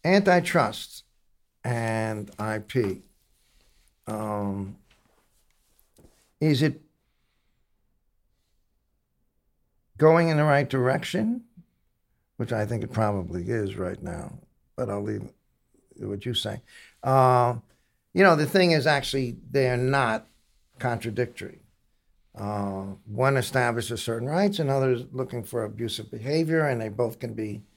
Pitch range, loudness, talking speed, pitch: 105-140 Hz, -26 LUFS, 110 wpm, 120 Hz